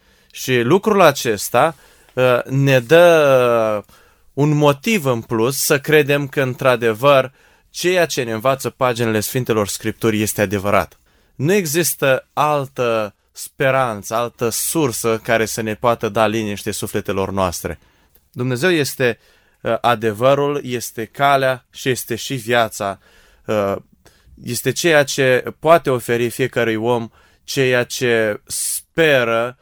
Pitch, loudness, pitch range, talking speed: 125 Hz, -17 LUFS, 110-135 Hz, 120 wpm